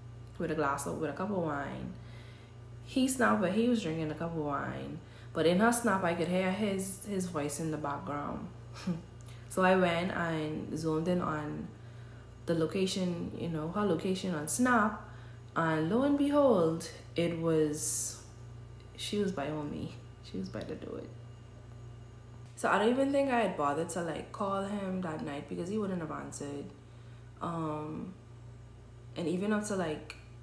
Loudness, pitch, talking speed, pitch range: -33 LUFS, 155 Hz, 175 wpm, 120-185 Hz